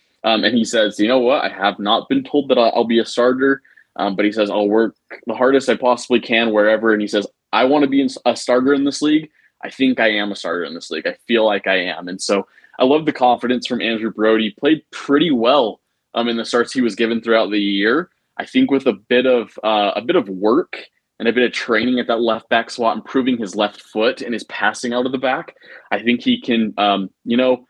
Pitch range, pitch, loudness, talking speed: 110-130 Hz, 120 Hz, -17 LUFS, 255 wpm